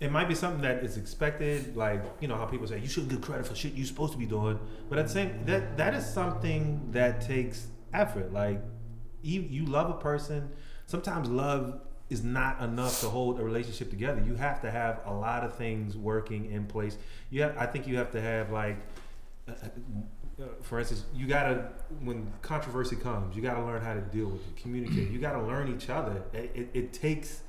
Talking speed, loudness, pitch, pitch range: 210 wpm, -33 LUFS, 120 Hz, 110-140 Hz